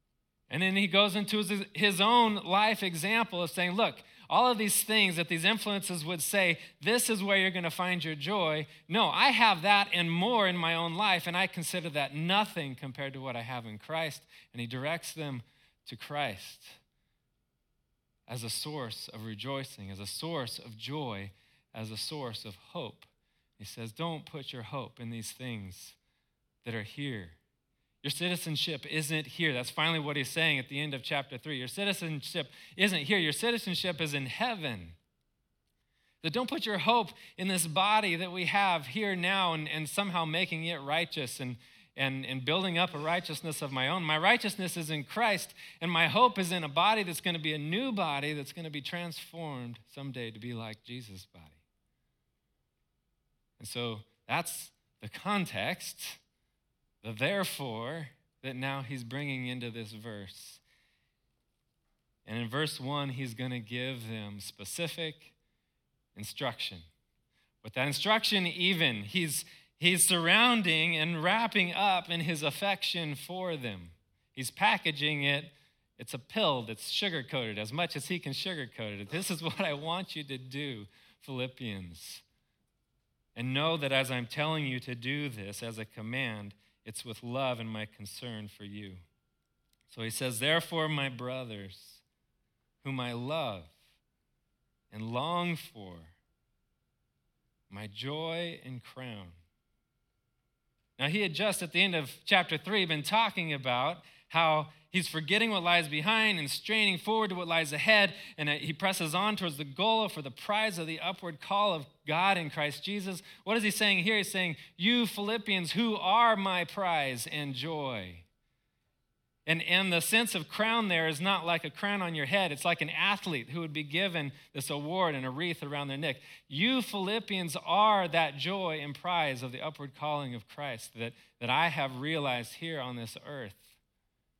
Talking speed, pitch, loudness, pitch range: 170 wpm, 155 Hz, -31 LUFS, 125-180 Hz